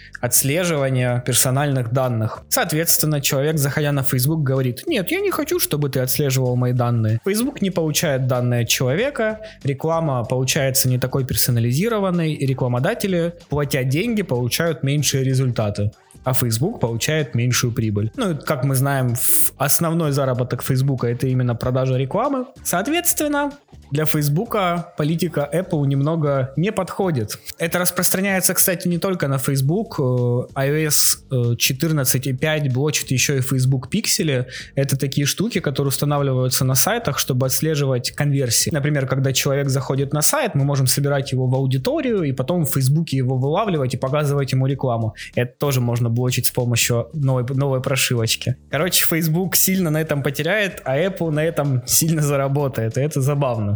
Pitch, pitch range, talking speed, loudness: 140 Hz, 130-160 Hz, 145 wpm, -19 LUFS